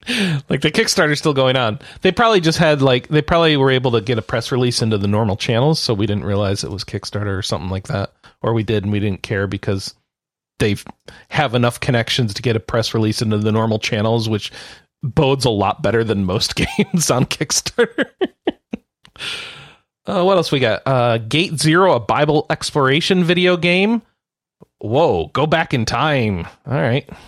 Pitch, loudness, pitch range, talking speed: 125 Hz, -17 LUFS, 110-155 Hz, 190 wpm